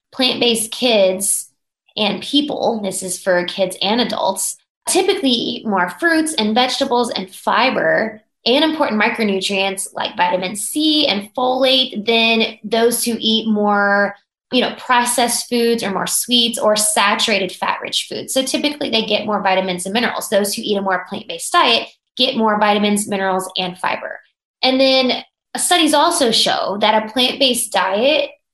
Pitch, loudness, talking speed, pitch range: 225 Hz, -16 LUFS, 155 wpm, 200-260 Hz